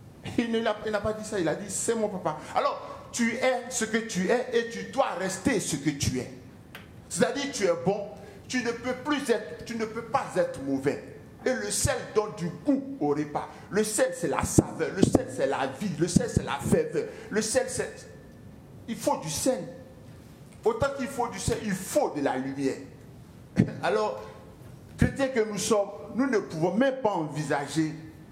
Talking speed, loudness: 205 wpm, -28 LUFS